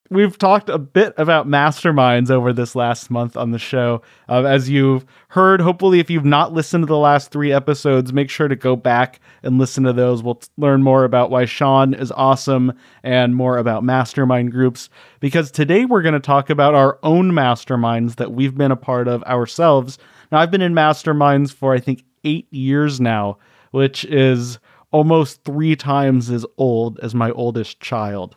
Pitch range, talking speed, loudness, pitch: 125-150 Hz, 190 wpm, -16 LUFS, 135 Hz